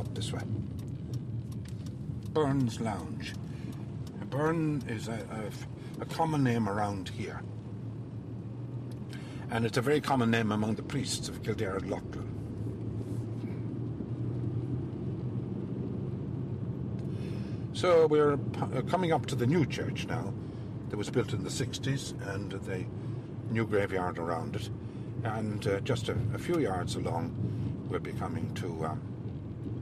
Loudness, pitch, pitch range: -33 LUFS, 120 Hz, 110-130 Hz